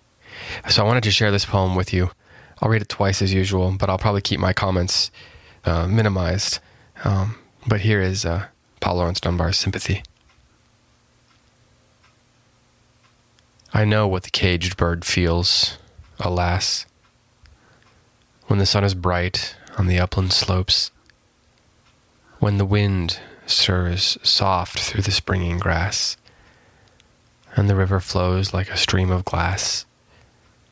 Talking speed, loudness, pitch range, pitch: 130 wpm, -20 LUFS, 90-110 Hz, 95 Hz